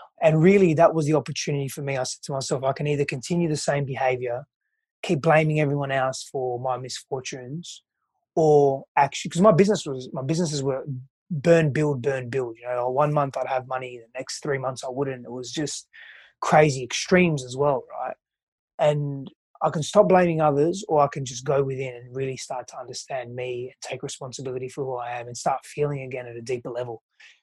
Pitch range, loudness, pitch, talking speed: 130-155 Hz, -24 LUFS, 140 Hz, 205 wpm